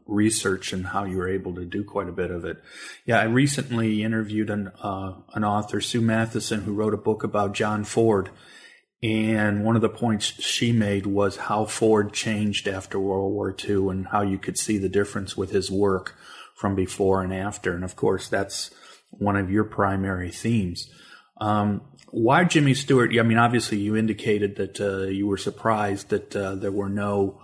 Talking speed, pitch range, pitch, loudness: 190 wpm, 95-110 Hz, 105 Hz, -24 LUFS